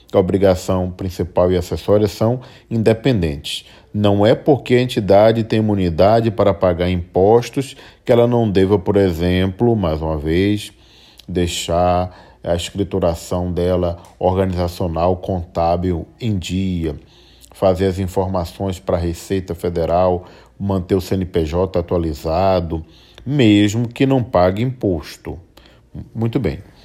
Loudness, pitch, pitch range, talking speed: -17 LUFS, 95 Hz, 90-105 Hz, 115 wpm